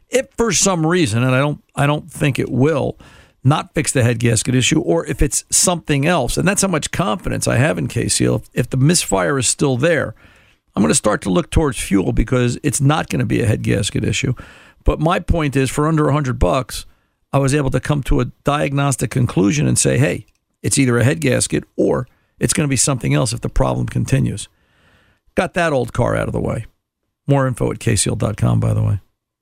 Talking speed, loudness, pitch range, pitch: 215 wpm, -17 LUFS, 120-150 Hz, 135 Hz